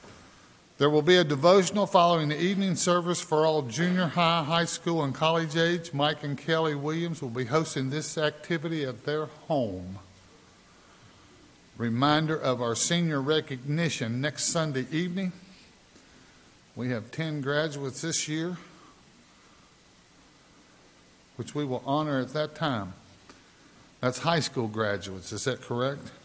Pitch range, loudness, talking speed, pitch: 125-165 Hz, -27 LUFS, 135 wpm, 150 Hz